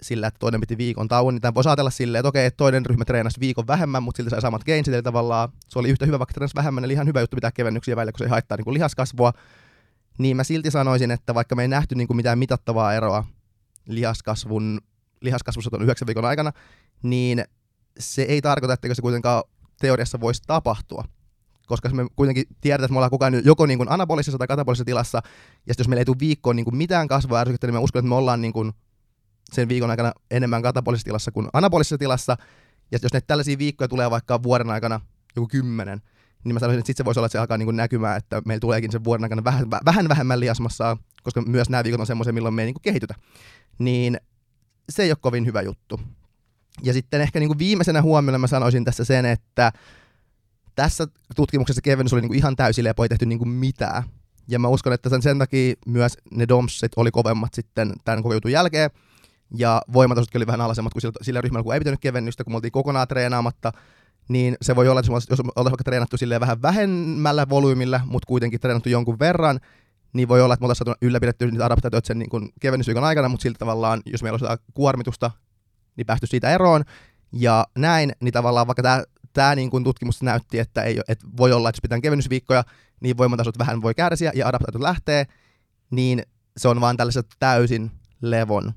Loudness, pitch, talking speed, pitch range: -21 LUFS, 120 Hz, 205 wpm, 115-130 Hz